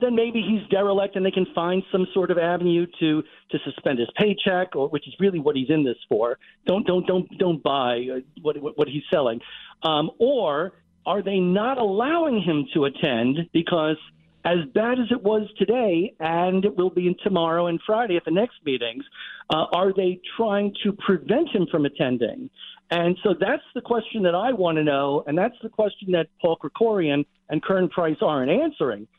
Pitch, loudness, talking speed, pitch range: 180 Hz, -23 LUFS, 195 wpm, 155-205 Hz